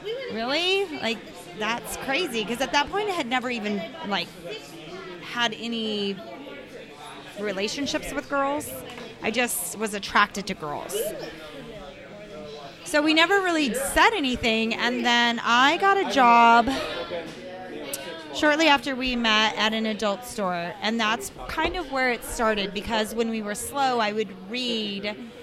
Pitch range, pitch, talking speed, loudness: 210-275 Hz, 230 Hz, 140 wpm, -24 LUFS